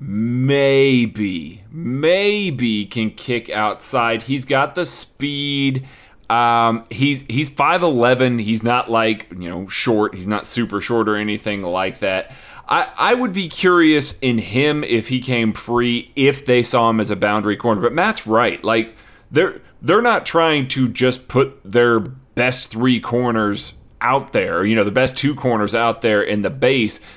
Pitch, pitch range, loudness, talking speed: 120 Hz, 110-135 Hz, -18 LUFS, 165 wpm